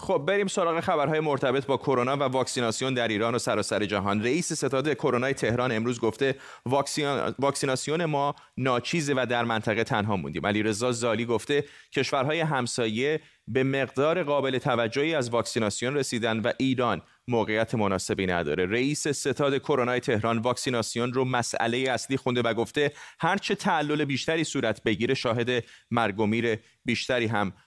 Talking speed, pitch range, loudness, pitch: 145 wpm, 115-140 Hz, -27 LUFS, 125 Hz